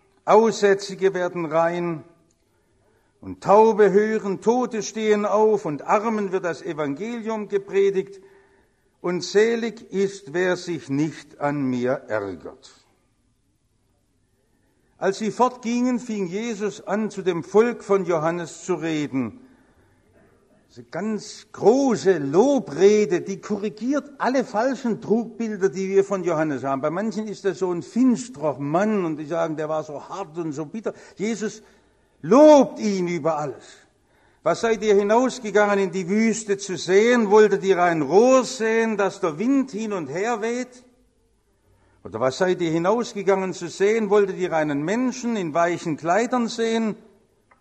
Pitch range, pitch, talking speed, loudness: 165-215 Hz, 195 Hz, 140 wpm, -22 LUFS